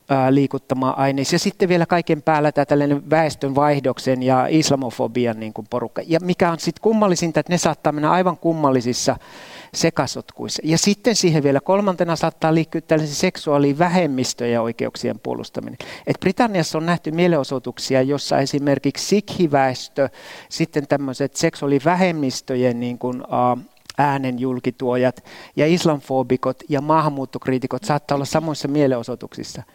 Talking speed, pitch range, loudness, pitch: 120 wpm, 130-165 Hz, -20 LUFS, 145 Hz